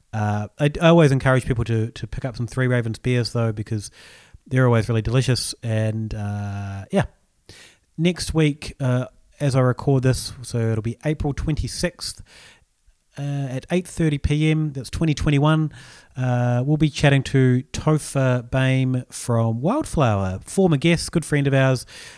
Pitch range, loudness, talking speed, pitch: 115-145 Hz, -21 LUFS, 150 wpm, 130 Hz